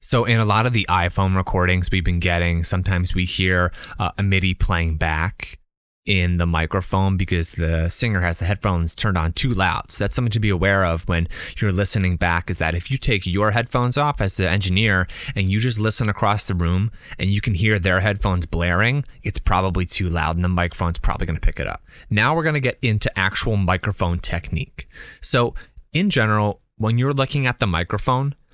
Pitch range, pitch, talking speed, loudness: 85-110 Hz, 95 Hz, 210 wpm, -21 LUFS